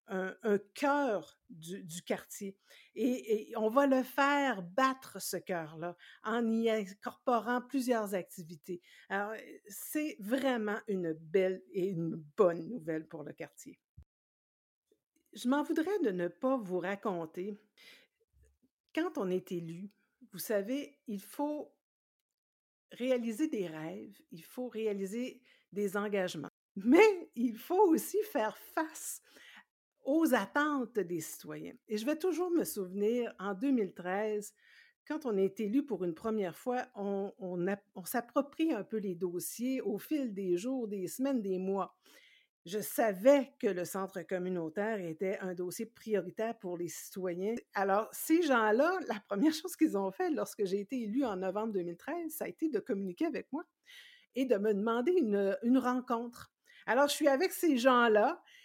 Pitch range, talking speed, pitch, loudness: 190-270 Hz, 150 wpm, 215 Hz, -34 LUFS